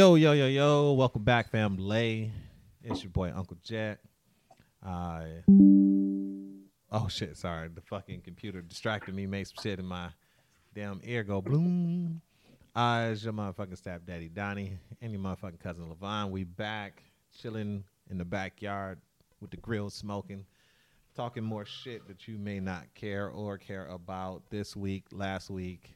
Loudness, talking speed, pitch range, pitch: -31 LUFS, 155 wpm, 95-110 Hz, 100 Hz